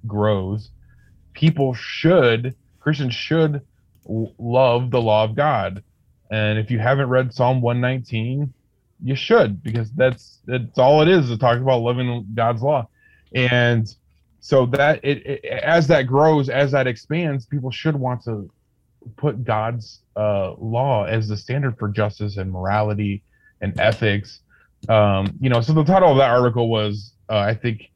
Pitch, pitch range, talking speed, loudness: 120 Hz, 110-135 Hz, 155 wpm, -19 LUFS